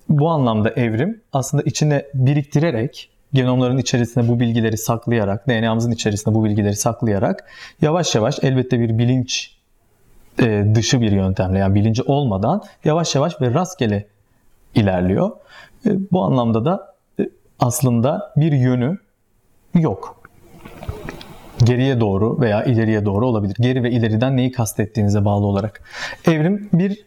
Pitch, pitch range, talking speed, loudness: 120 Hz, 110-140 Hz, 120 wpm, -18 LUFS